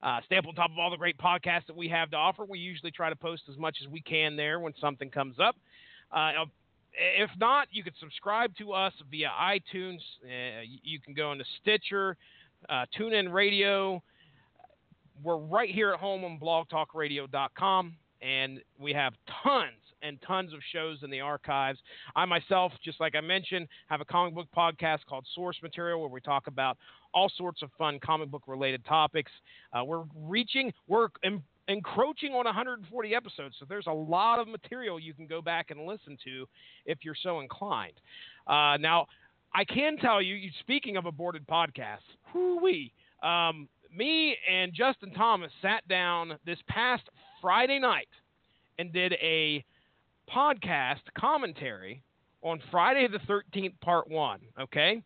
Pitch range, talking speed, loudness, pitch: 150-195 Hz, 165 wpm, -30 LUFS, 170 Hz